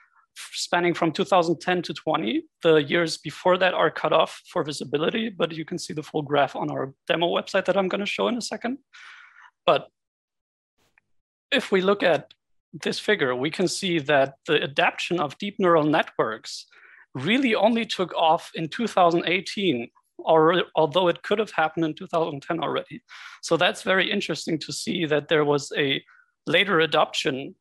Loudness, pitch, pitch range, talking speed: -24 LUFS, 175 Hz, 160-205 Hz, 165 wpm